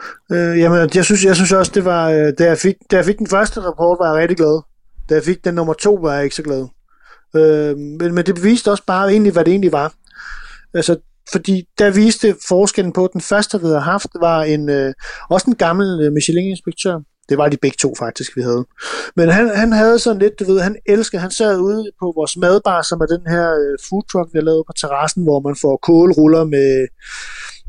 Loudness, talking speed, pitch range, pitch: -15 LUFS, 225 wpm, 155-195 Hz, 175 Hz